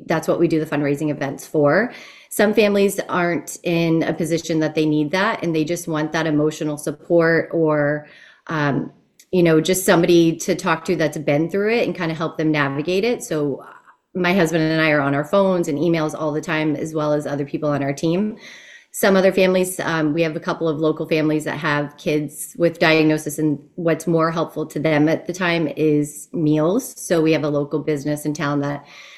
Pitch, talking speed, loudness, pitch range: 160 Hz, 210 wpm, -19 LUFS, 150-175 Hz